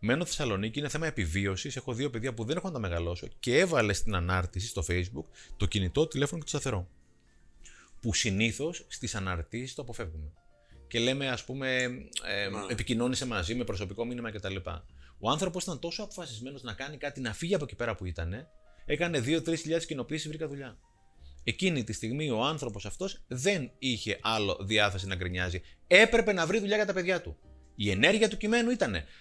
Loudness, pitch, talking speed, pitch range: -31 LUFS, 120 Hz, 185 wpm, 95-150 Hz